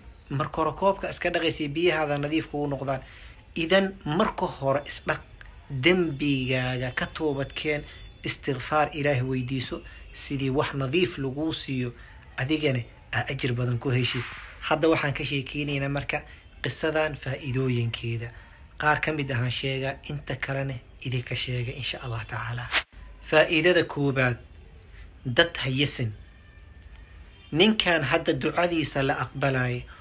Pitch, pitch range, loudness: 135 Hz, 125-155 Hz, -27 LUFS